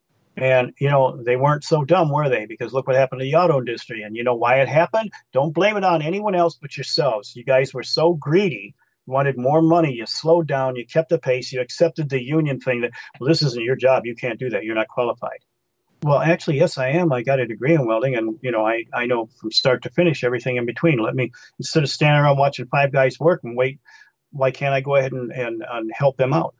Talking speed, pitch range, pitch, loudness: 255 wpm, 125-160 Hz, 135 Hz, -20 LUFS